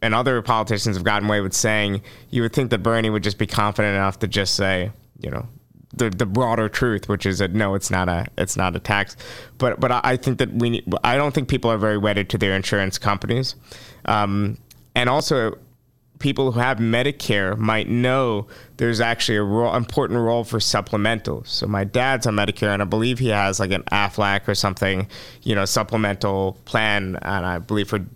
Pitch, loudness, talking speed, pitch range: 110 Hz, -21 LUFS, 205 wpm, 100-120 Hz